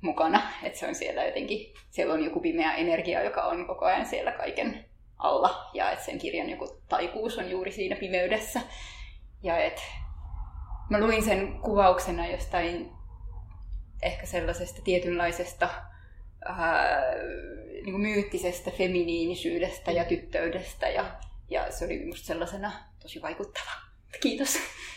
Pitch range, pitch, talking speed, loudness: 130-205 Hz, 180 Hz, 130 wpm, -29 LUFS